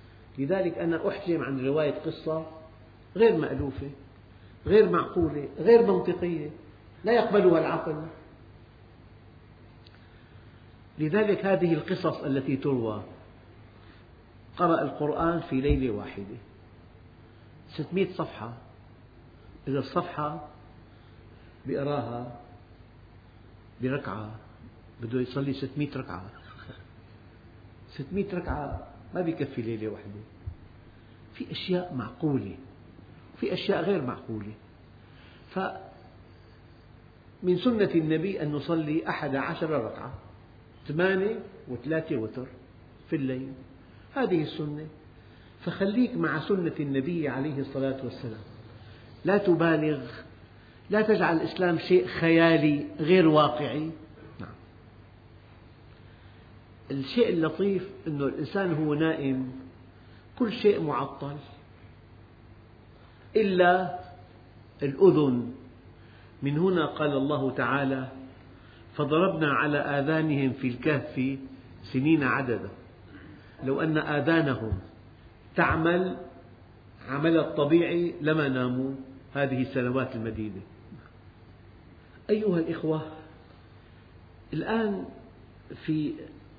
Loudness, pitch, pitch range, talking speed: -27 LUFS, 130 Hz, 110-155 Hz, 80 wpm